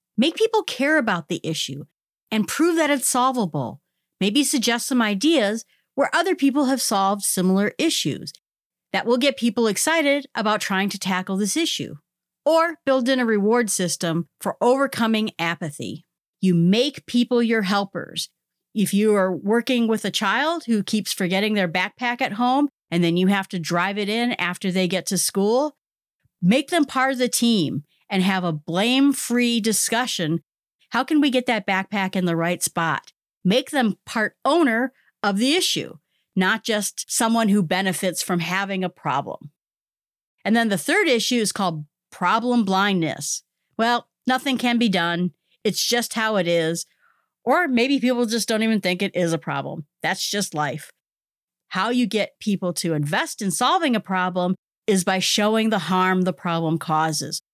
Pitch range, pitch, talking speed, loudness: 185-245 Hz, 210 Hz, 170 wpm, -21 LUFS